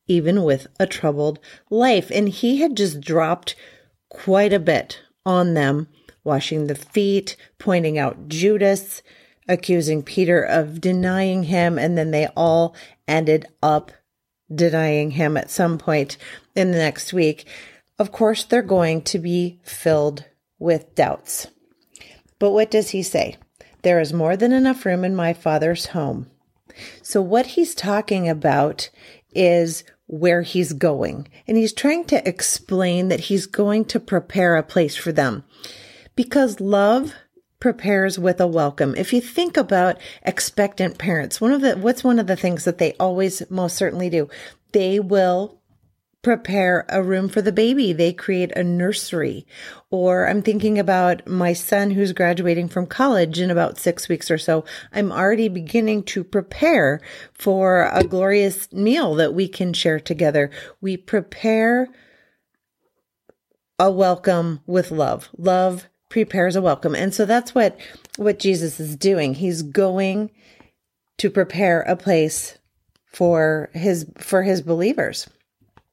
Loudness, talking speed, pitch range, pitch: -20 LUFS, 145 wpm, 165-205 Hz, 185 Hz